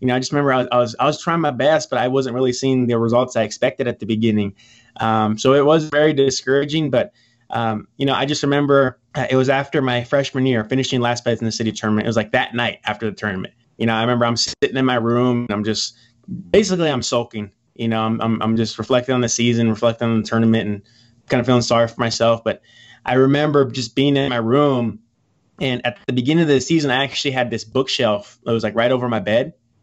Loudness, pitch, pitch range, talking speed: -18 LUFS, 120 Hz, 115-135 Hz, 245 wpm